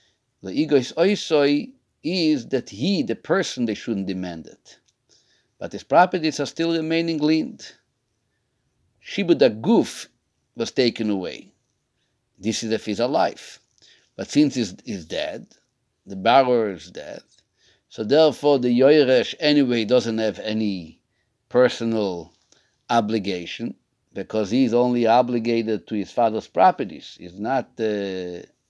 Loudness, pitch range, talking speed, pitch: -21 LUFS, 110-140 Hz, 125 wpm, 120 Hz